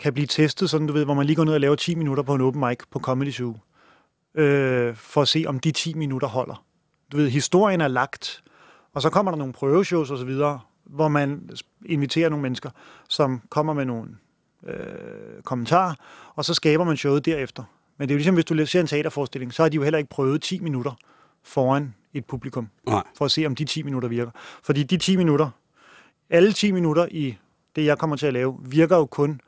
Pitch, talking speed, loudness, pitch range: 145 Hz, 225 wpm, -23 LUFS, 135-160 Hz